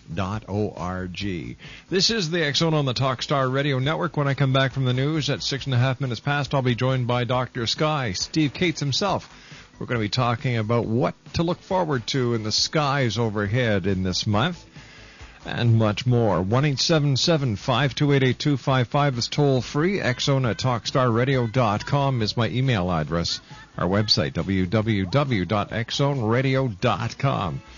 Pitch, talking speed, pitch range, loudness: 130 Hz, 155 wpm, 110-140 Hz, -23 LUFS